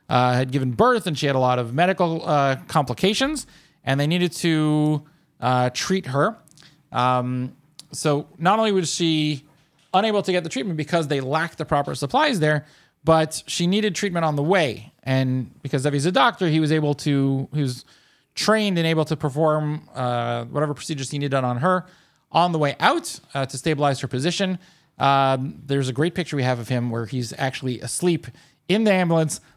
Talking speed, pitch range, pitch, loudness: 190 wpm, 135-170 Hz, 150 Hz, -22 LUFS